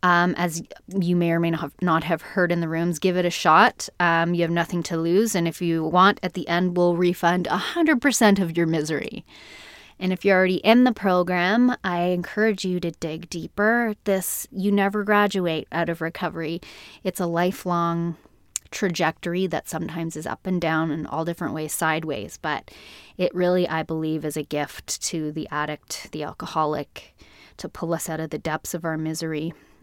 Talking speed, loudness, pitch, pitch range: 185 wpm, -23 LUFS, 170 Hz, 160-185 Hz